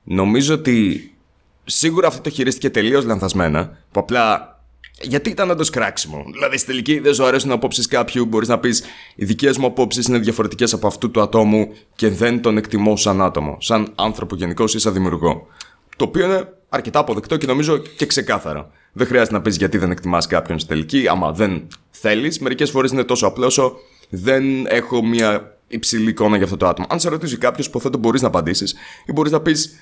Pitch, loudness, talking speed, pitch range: 115 Hz, -17 LUFS, 190 wpm, 105-135 Hz